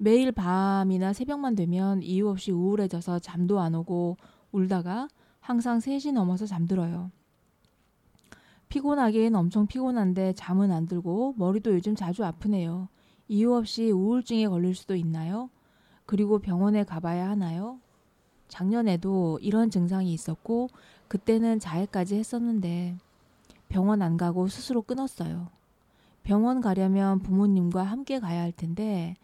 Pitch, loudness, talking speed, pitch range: 195 Hz, -27 LUFS, 290 characters per minute, 180-225 Hz